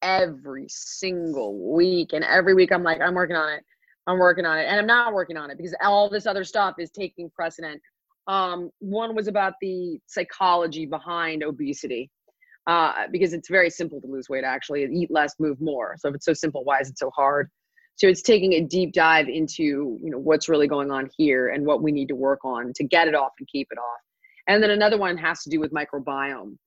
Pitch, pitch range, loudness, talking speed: 165 Hz, 145-185 Hz, -23 LUFS, 225 wpm